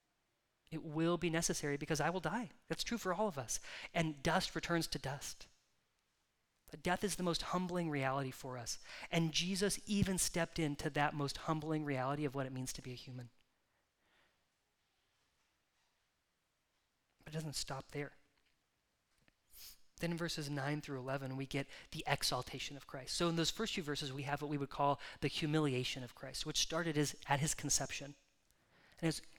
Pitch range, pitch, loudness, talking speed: 140-170 Hz, 150 Hz, -39 LUFS, 175 wpm